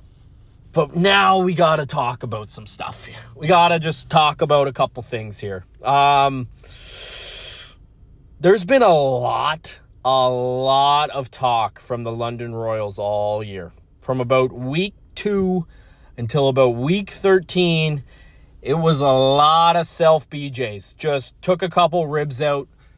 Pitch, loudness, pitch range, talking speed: 140 Hz, -19 LUFS, 120-165 Hz, 145 wpm